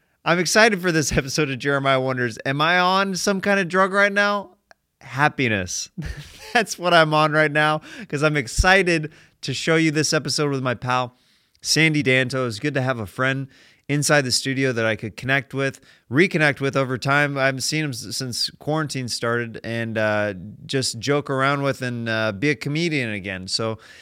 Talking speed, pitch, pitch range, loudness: 190 wpm, 140 Hz, 125-155 Hz, -21 LUFS